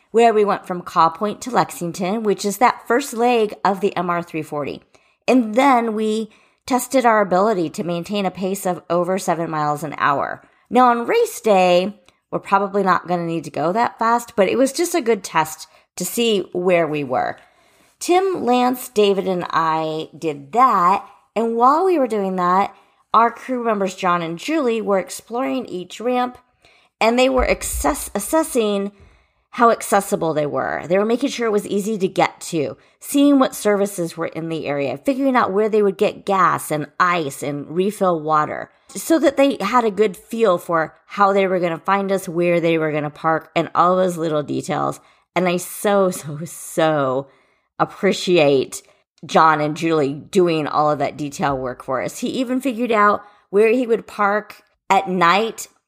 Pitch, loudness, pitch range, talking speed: 195 Hz, -19 LUFS, 165-230 Hz, 180 wpm